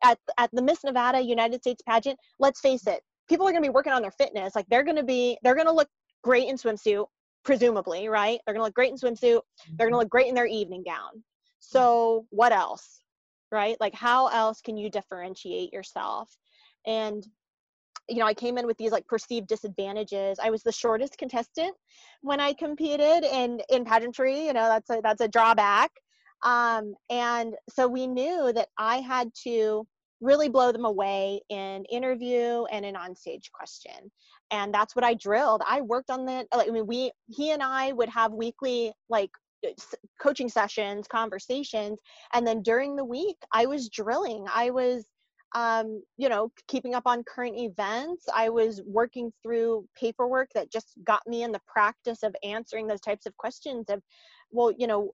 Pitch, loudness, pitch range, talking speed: 235 Hz, -27 LUFS, 220-255 Hz, 190 wpm